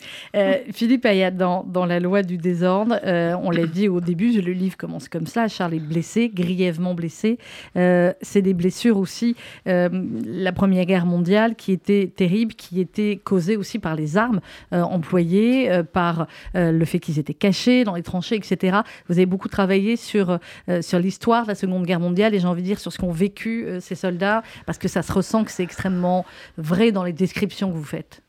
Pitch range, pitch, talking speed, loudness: 180-205 Hz, 185 Hz, 210 wpm, -21 LUFS